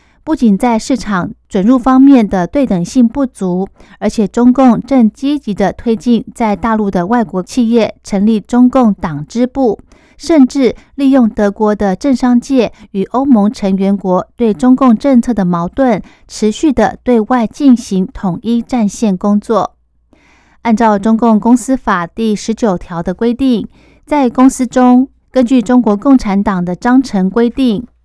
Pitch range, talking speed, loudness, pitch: 205-255 Hz, 230 characters per minute, -12 LUFS, 230 Hz